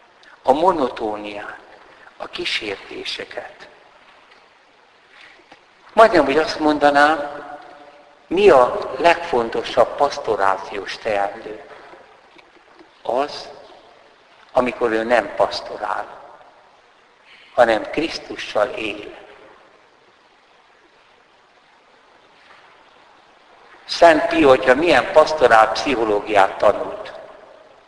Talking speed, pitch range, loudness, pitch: 60 wpm, 110-145 Hz, -18 LUFS, 145 Hz